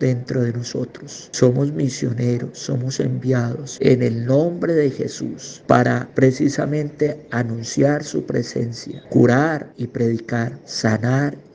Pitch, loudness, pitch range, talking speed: 125 Hz, -20 LUFS, 120-140 Hz, 110 wpm